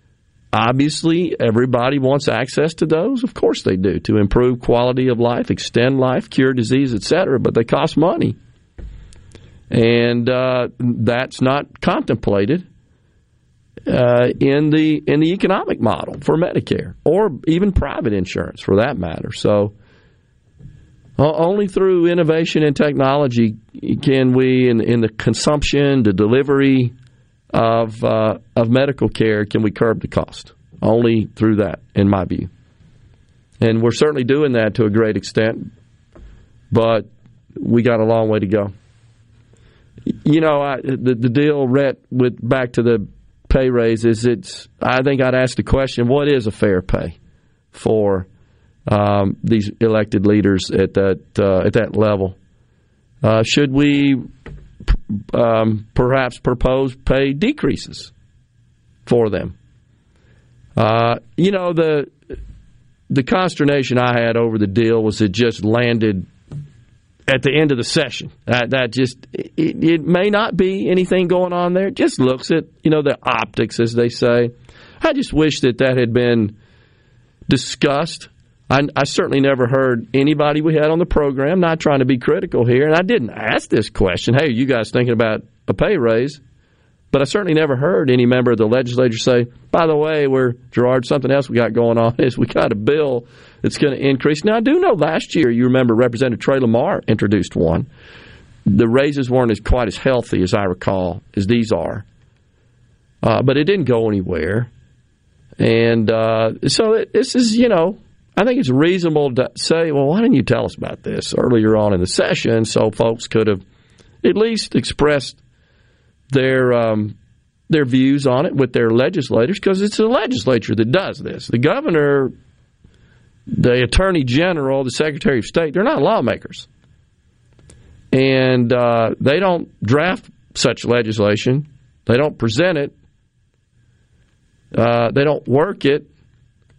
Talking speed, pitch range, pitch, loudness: 160 wpm, 115-140 Hz, 125 Hz, -16 LUFS